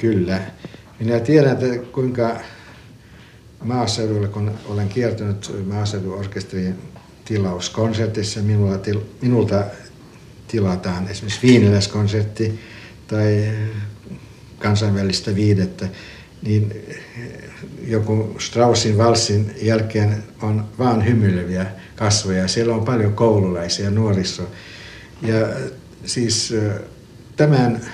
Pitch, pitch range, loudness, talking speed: 110 Hz, 100-115 Hz, -19 LUFS, 80 wpm